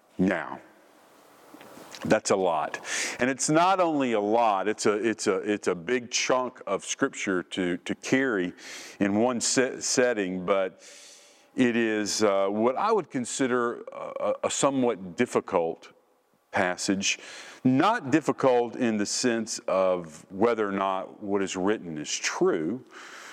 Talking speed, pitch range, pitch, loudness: 140 wpm, 95-125 Hz, 110 Hz, -26 LUFS